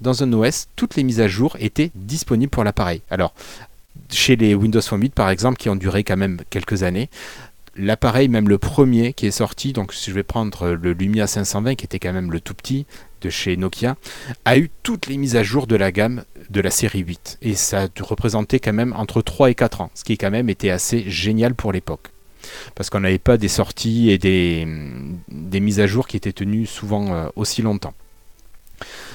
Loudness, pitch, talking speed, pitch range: -19 LUFS, 105 Hz, 215 wpm, 95-120 Hz